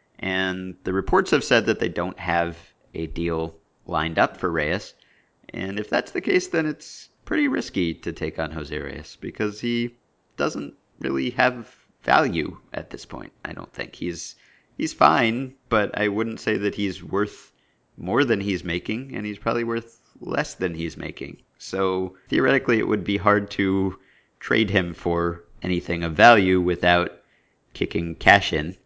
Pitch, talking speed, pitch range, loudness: 95 Hz, 165 wpm, 85-110 Hz, -23 LUFS